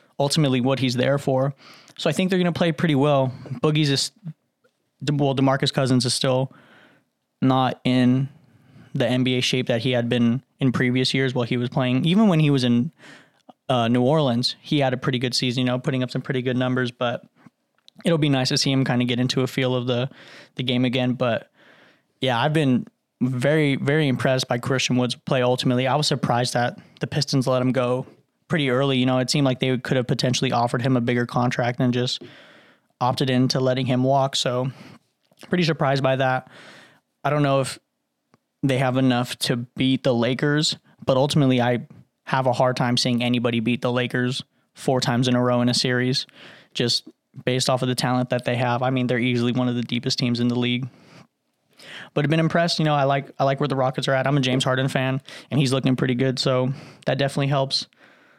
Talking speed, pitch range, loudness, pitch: 215 wpm, 125-140 Hz, -22 LUFS, 130 Hz